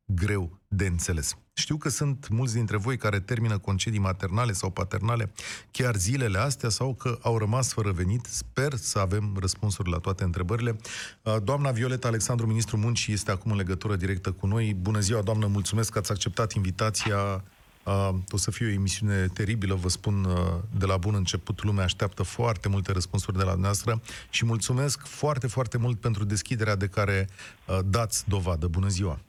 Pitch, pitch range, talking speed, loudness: 105 Hz, 95-115 Hz, 170 wpm, -28 LUFS